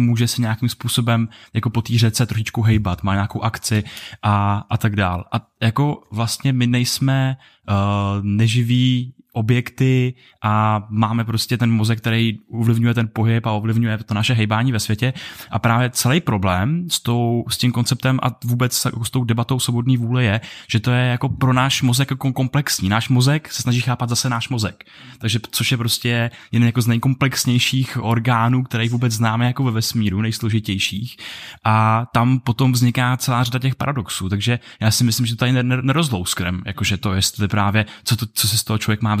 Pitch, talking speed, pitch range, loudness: 115 Hz, 180 wpm, 110-125 Hz, -19 LUFS